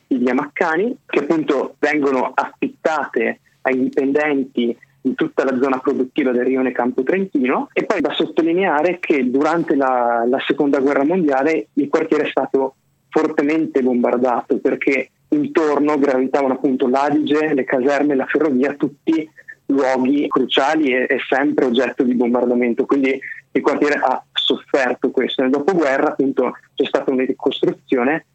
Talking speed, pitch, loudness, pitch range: 140 wpm, 140 Hz, -18 LUFS, 130-150 Hz